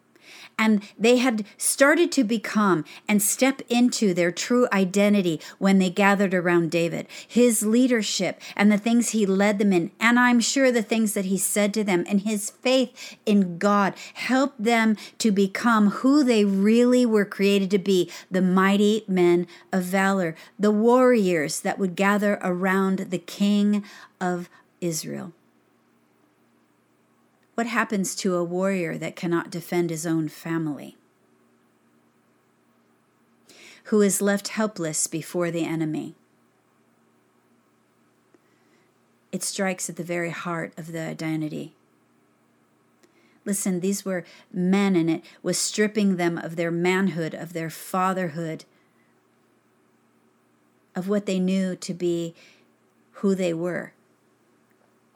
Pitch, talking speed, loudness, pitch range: 190 Hz, 130 wpm, -23 LUFS, 165-210 Hz